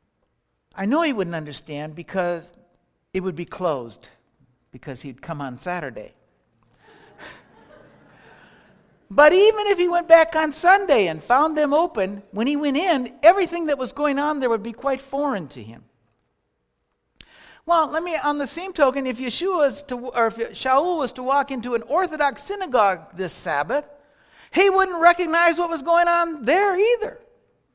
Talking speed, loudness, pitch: 160 wpm, -21 LUFS, 265 Hz